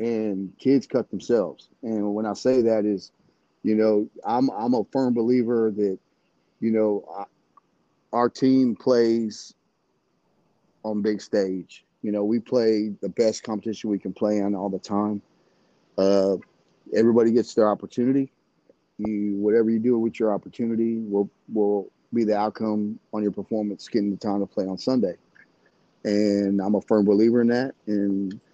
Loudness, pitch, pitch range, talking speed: -24 LUFS, 105 Hz, 100-115 Hz, 160 wpm